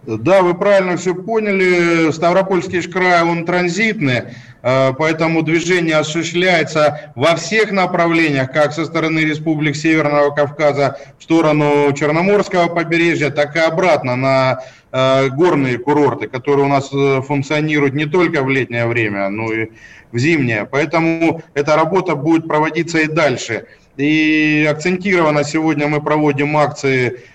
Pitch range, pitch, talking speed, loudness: 140-170 Hz, 155 Hz, 125 wpm, -15 LUFS